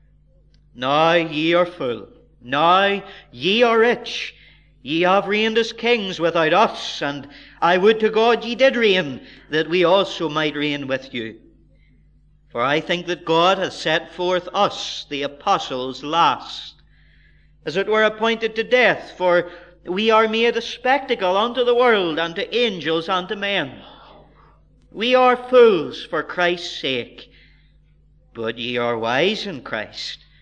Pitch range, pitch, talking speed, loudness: 145-220 Hz, 175 Hz, 145 wpm, -19 LUFS